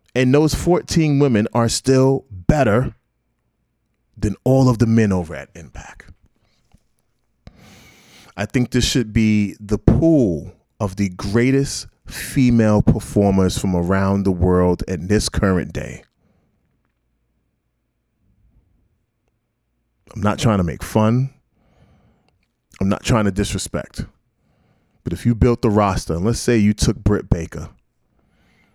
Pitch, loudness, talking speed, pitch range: 105 Hz, -18 LUFS, 120 wpm, 95-120 Hz